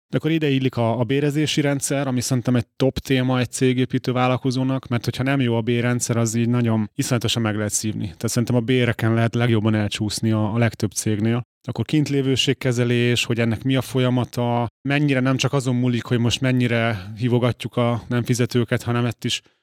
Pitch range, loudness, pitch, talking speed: 115-130 Hz, -21 LUFS, 120 Hz, 190 wpm